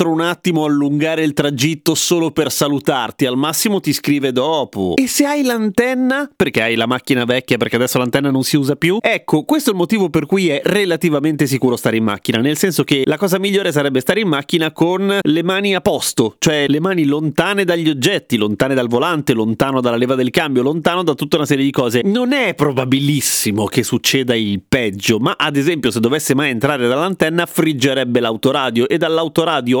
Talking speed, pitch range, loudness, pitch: 195 wpm, 130-175 Hz, -16 LUFS, 150 Hz